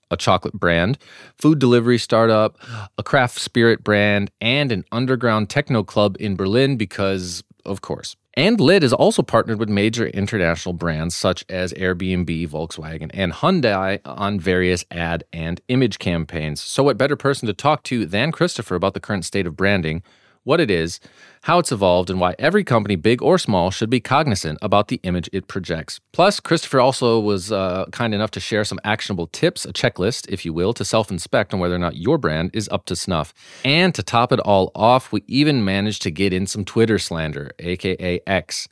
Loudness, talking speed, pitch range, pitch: -19 LUFS, 190 wpm, 90-120 Hz, 100 Hz